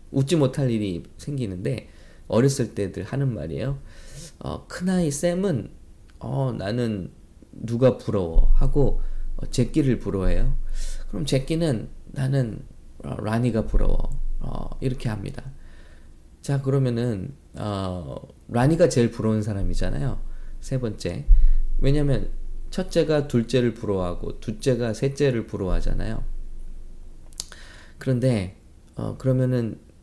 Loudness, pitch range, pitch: -25 LUFS, 90-135 Hz, 115 Hz